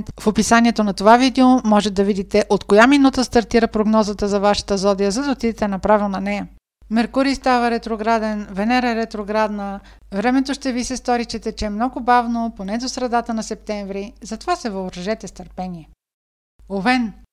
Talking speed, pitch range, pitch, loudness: 165 wpm, 205-240 Hz, 220 Hz, -18 LUFS